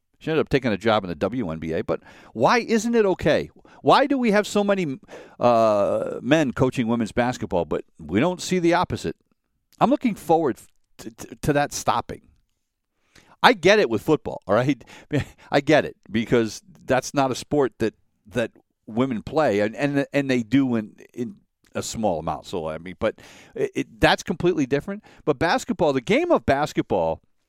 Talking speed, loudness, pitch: 180 wpm, -22 LUFS, 140 Hz